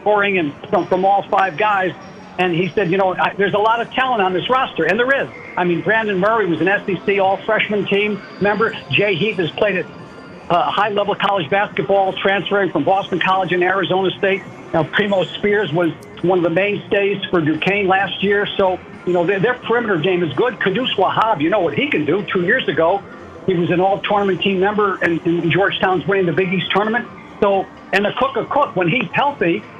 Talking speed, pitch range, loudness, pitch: 215 wpm, 185-205 Hz, -17 LUFS, 195 Hz